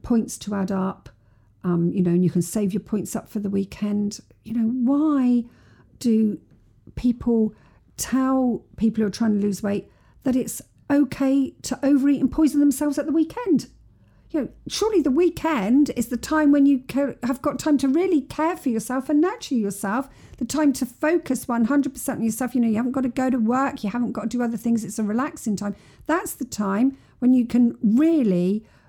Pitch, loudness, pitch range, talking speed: 245 Hz, -22 LUFS, 215-280 Hz, 200 wpm